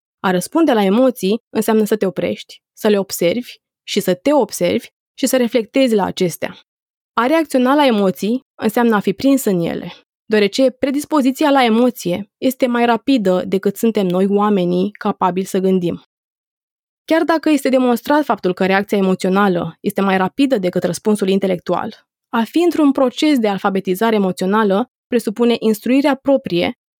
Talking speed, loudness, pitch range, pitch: 150 wpm, -16 LUFS, 195-260 Hz, 220 Hz